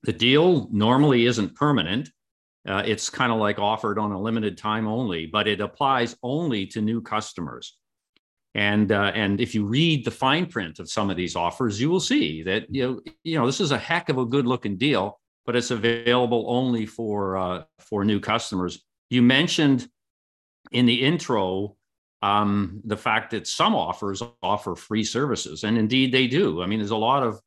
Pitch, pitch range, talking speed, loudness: 110 Hz, 100-125 Hz, 190 wpm, -23 LUFS